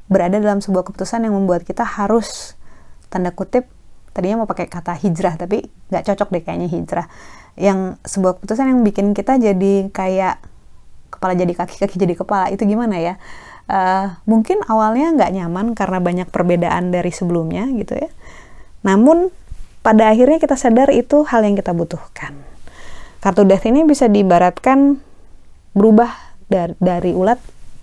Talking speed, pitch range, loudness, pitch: 145 wpm, 180-225 Hz, -16 LUFS, 195 Hz